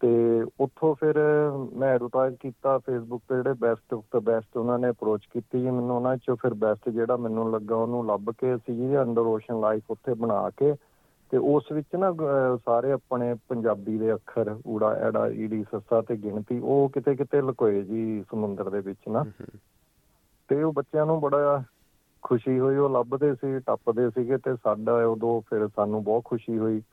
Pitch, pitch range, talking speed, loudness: 120 Hz, 110-135 Hz, 175 wpm, -26 LUFS